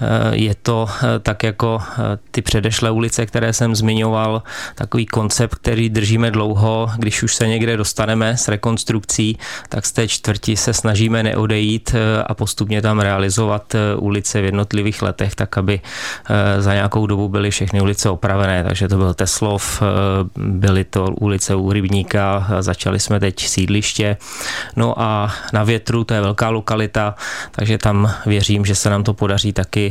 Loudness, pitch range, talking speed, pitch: -17 LUFS, 100-110 Hz, 155 wpm, 105 Hz